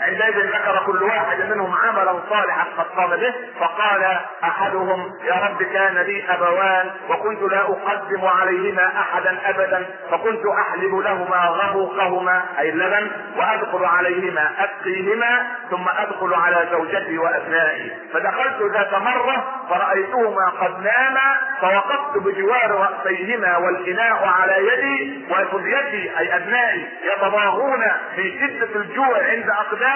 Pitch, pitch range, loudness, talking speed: 195 Hz, 185-215 Hz, -19 LUFS, 115 wpm